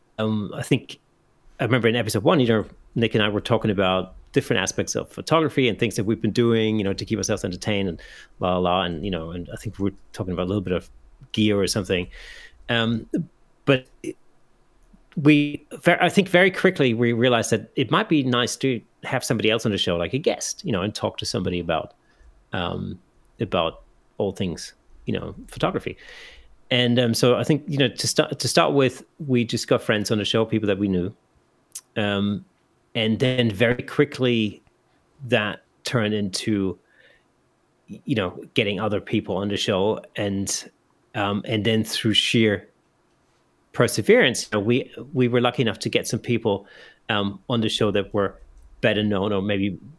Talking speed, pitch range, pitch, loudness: 190 wpm, 100-125 Hz, 110 Hz, -23 LUFS